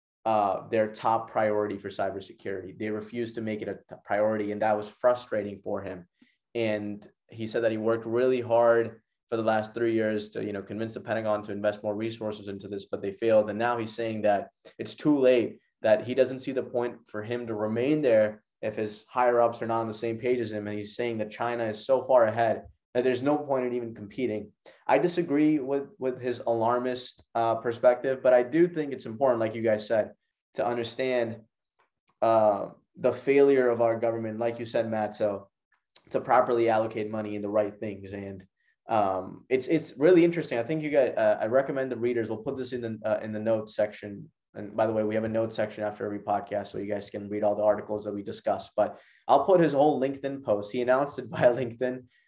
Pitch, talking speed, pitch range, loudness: 115 Hz, 220 wpm, 105-125 Hz, -27 LUFS